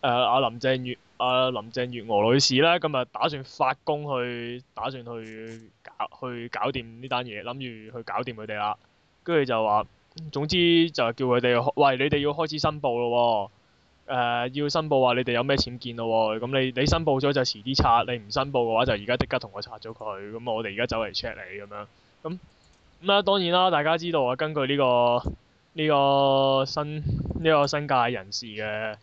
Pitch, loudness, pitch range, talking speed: 125 Hz, -25 LUFS, 115-145 Hz, 300 characters per minute